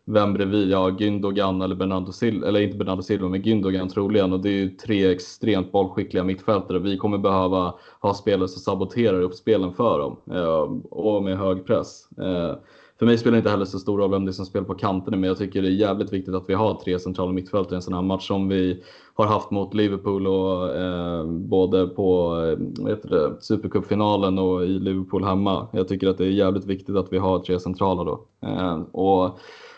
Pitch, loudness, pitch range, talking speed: 95 Hz, -23 LUFS, 95-100 Hz, 210 wpm